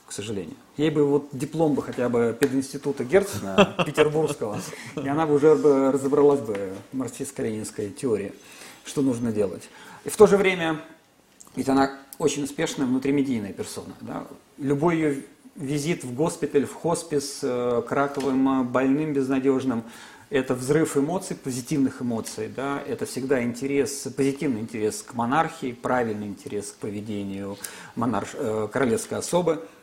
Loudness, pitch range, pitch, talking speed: -25 LUFS, 125-150 Hz, 140 Hz, 135 wpm